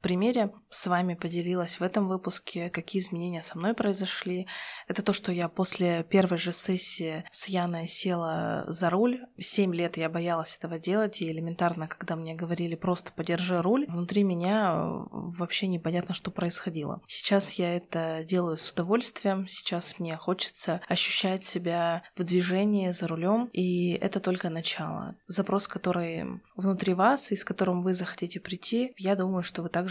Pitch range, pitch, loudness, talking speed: 170-195 Hz, 180 Hz, -29 LUFS, 160 wpm